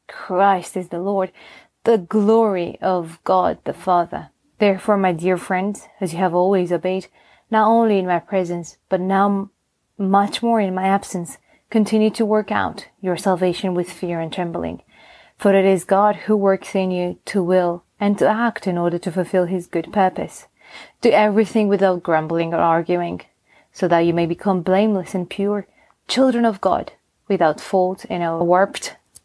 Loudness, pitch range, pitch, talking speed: -19 LUFS, 180-205 Hz, 190 Hz, 170 wpm